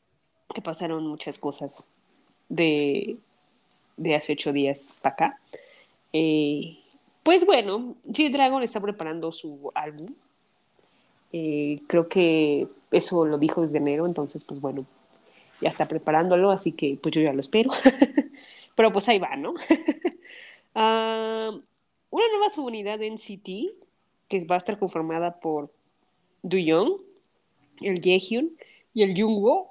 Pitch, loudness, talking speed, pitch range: 190 Hz, -25 LUFS, 125 wpm, 155-245 Hz